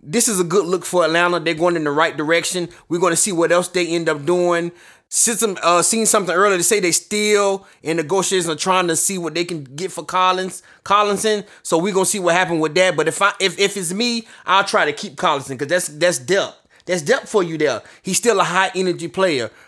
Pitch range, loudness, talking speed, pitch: 170-195 Hz, -17 LUFS, 245 wpm, 180 Hz